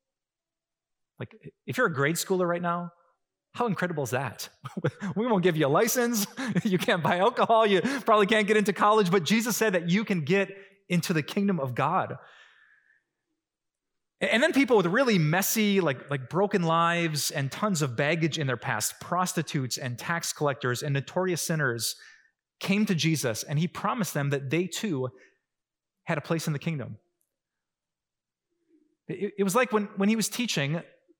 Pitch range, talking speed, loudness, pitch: 155-215 Hz, 170 wpm, -26 LUFS, 180 Hz